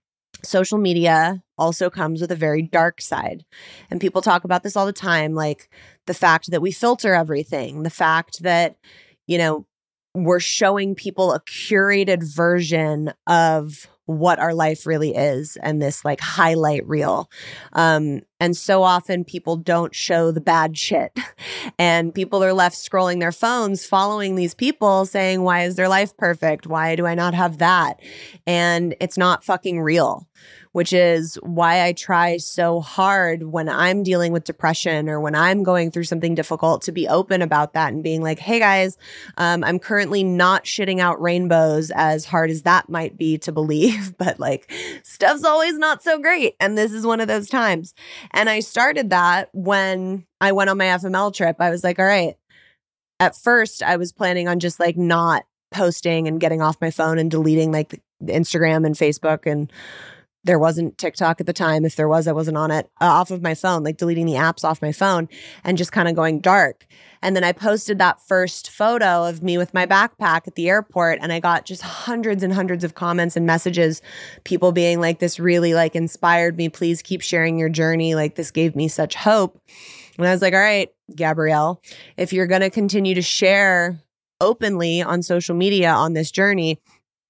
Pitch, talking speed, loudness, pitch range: 175 Hz, 190 wpm, -19 LUFS, 160-190 Hz